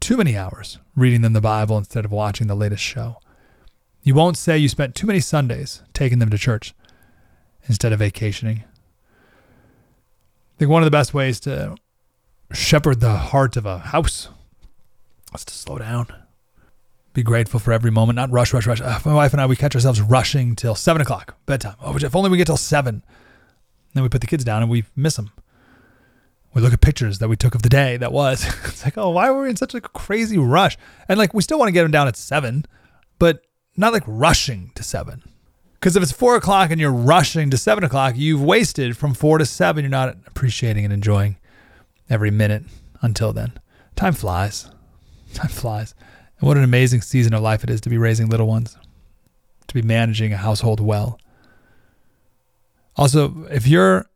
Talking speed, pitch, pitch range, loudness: 200 wpm, 125 Hz, 110-145 Hz, -18 LUFS